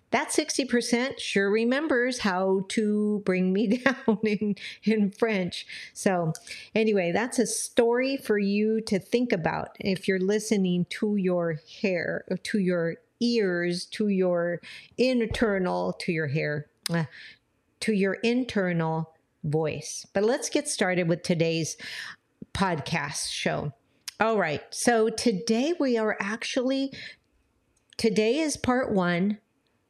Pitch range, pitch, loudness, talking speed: 175-230 Hz, 205 Hz, -27 LUFS, 120 wpm